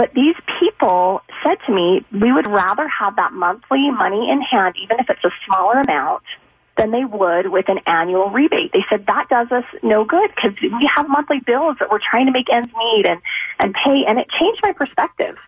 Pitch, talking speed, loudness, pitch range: 245 Hz, 215 wpm, -16 LUFS, 195-290 Hz